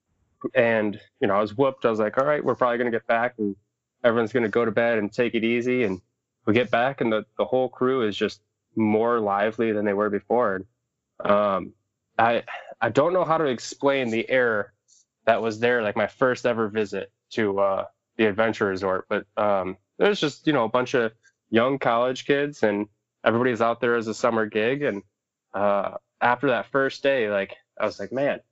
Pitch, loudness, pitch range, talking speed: 115 Hz, -24 LUFS, 105-125 Hz, 210 wpm